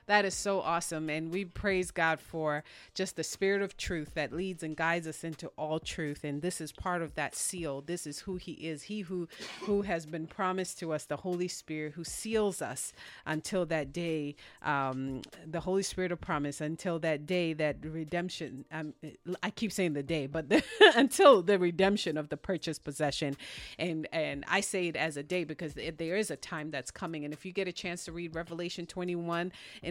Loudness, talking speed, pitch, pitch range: -33 LUFS, 210 wpm, 165 Hz, 155-185 Hz